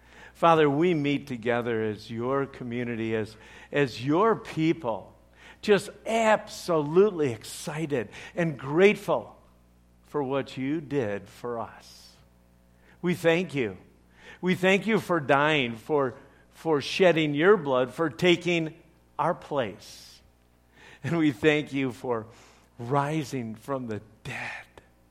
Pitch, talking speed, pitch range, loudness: 135 Hz, 115 wpm, 110-165 Hz, -26 LUFS